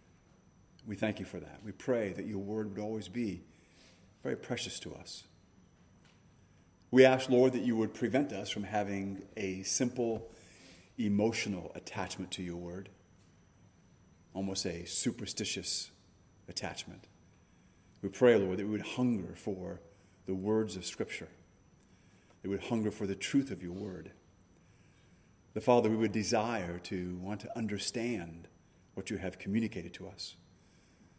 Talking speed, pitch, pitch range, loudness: 145 wpm, 95 Hz, 90-110 Hz, -34 LUFS